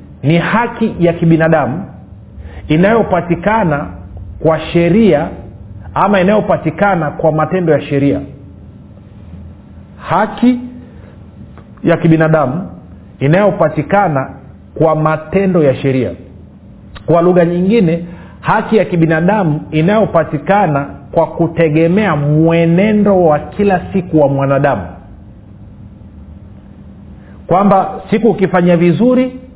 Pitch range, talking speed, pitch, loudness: 130-190 Hz, 80 wpm, 160 Hz, -12 LUFS